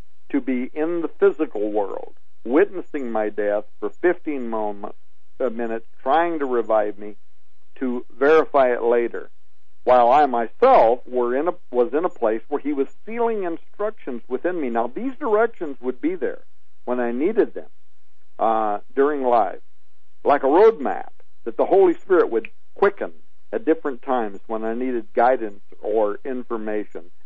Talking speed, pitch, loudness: 150 wpm, 130 Hz, -21 LUFS